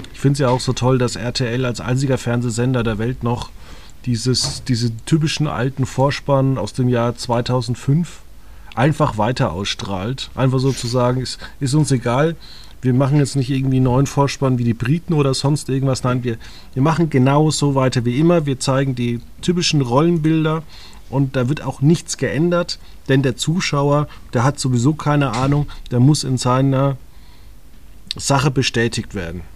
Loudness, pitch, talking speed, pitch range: -18 LUFS, 130 Hz, 170 wpm, 120-140 Hz